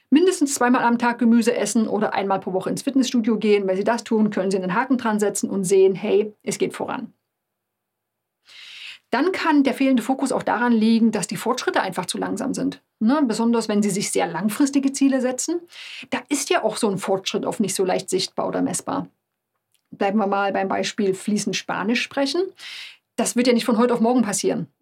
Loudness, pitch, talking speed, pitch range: -21 LUFS, 230 Hz, 200 wpm, 200-260 Hz